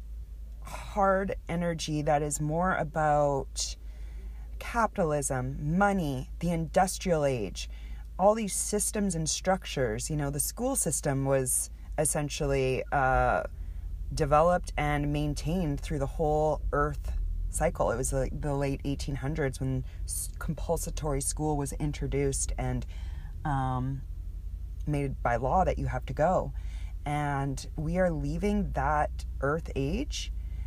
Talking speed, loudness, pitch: 120 wpm, -30 LUFS, 140 Hz